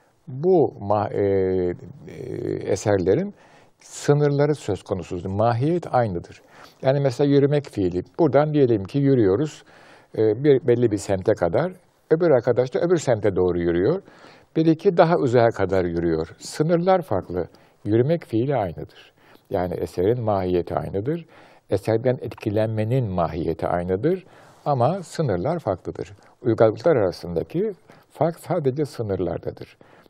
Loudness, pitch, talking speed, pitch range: -22 LUFS, 125 Hz, 110 wpm, 100-150 Hz